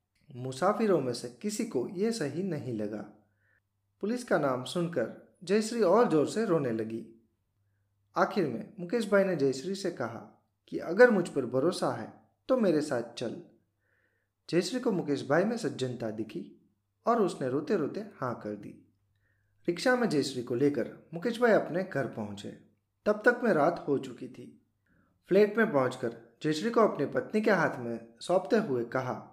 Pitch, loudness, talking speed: 140 Hz, -30 LUFS, 165 wpm